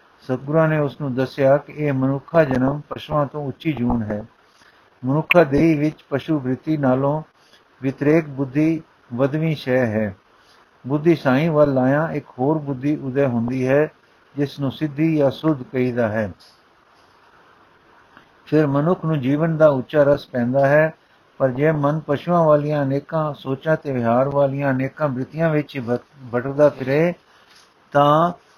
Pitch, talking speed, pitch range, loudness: 140 Hz, 140 wpm, 130-155 Hz, -20 LUFS